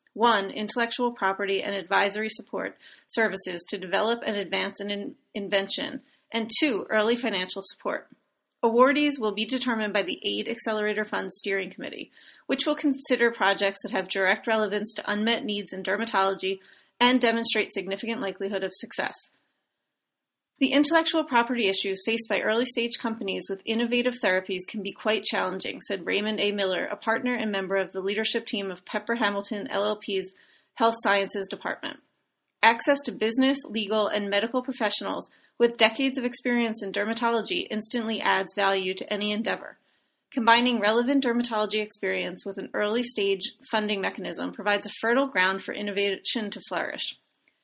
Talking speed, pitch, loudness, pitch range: 150 wpm, 215 Hz, -25 LUFS, 195-235 Hz